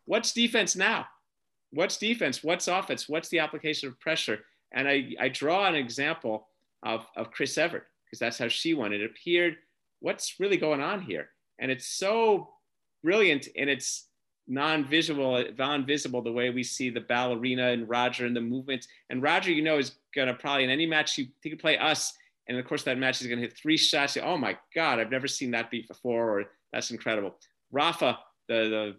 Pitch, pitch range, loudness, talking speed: 140 Hz, 125-160 Hz, -28 LUFS, 195 wpm